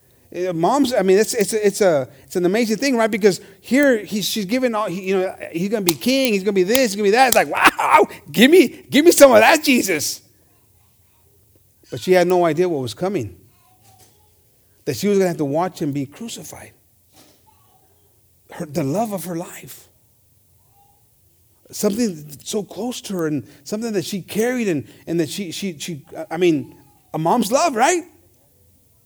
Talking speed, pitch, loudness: 195 wpm, 170 Hz, -18 LUFS